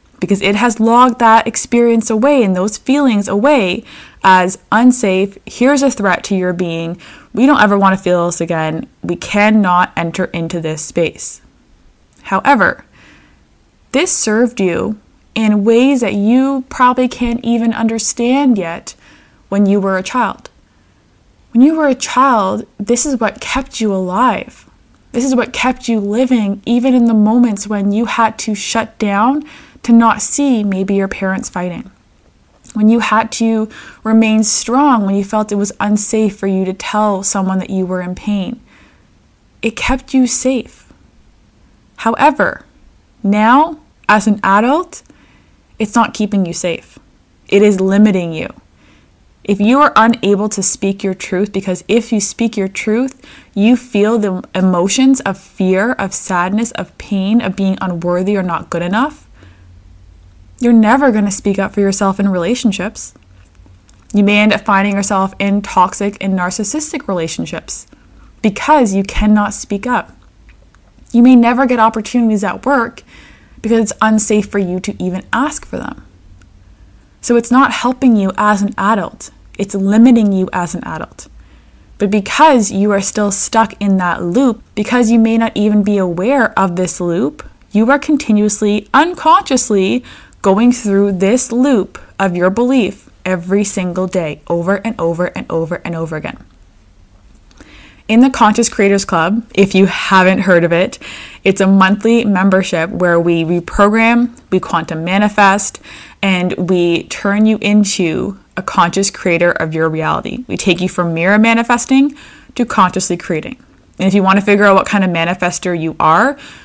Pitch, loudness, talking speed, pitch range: 205 Hz, -13 LUFS, 160 wpm, 185-235 Hz